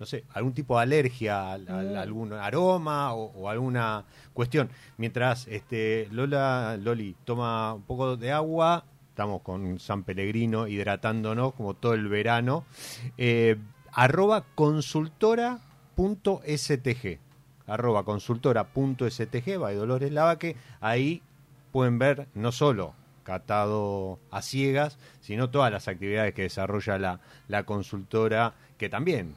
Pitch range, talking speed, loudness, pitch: 105-140 Hz, 135 wpm, -28 LUFS, 120 Hz